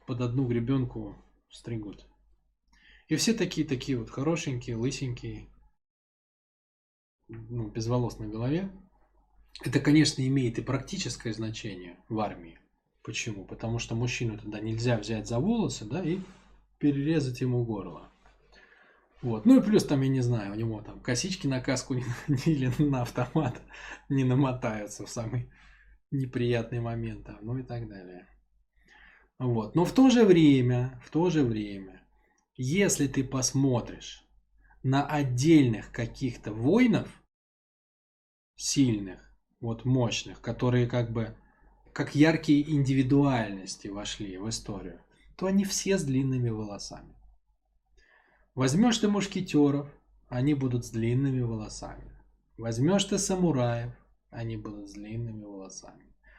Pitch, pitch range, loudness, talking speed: 125 Hz, 115-145 Hz, -28 LUFS, 120 wpm